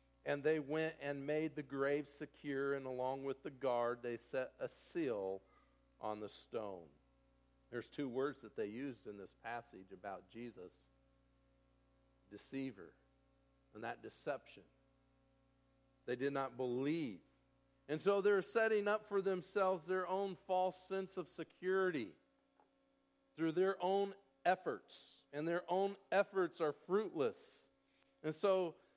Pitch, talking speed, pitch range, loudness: 150 Hz, 135 wpm, 135-185 Hz, -41 LUFS